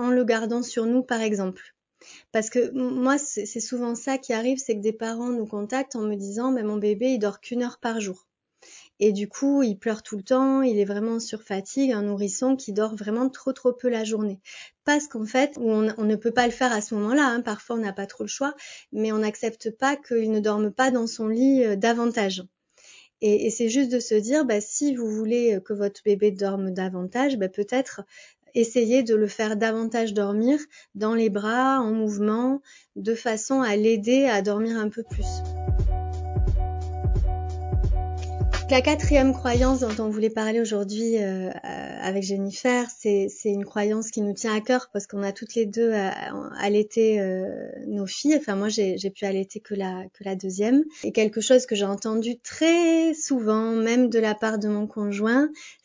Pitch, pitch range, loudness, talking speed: 220 Hz, 205-250 Hz, -24 LUFS, 200 wpm